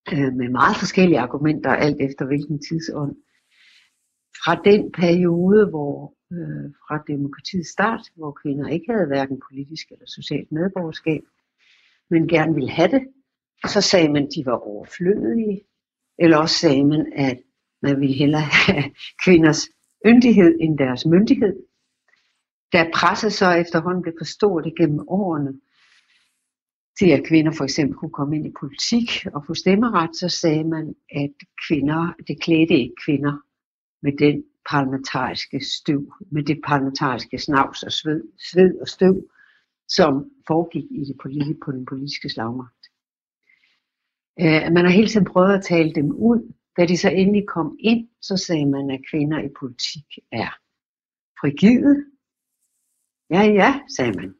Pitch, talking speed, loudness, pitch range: 160 Hz, 145 wpm, -19 LUFS, 145-185 Hz